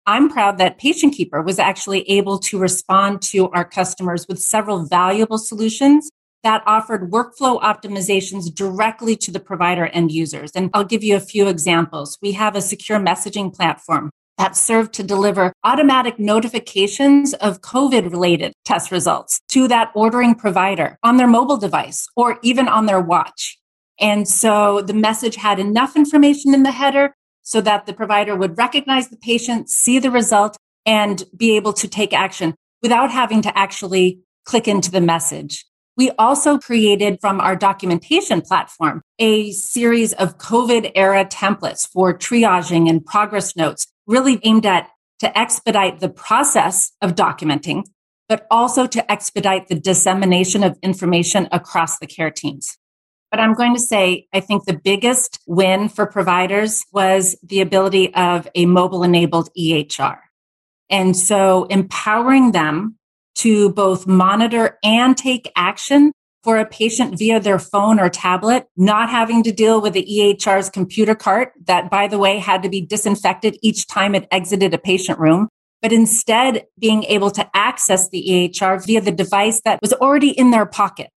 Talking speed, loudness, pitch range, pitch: 160 wpm, -16 LUFS, 185-225 Hz, 205 Hz